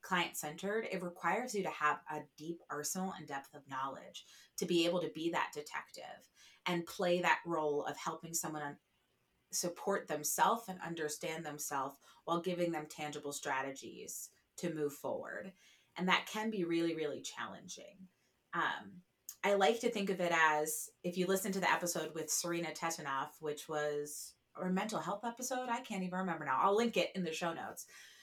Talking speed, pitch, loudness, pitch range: 175 wpm, 170 Hz, -37 LUFS, 150-185 Hz